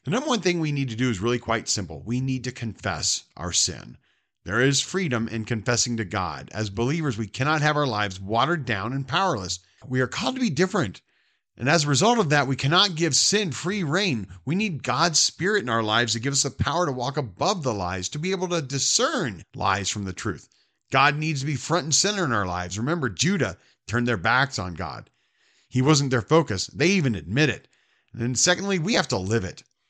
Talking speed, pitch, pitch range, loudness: 225 wpm, 130 Hz, 115-165 Hz, -24 LUFS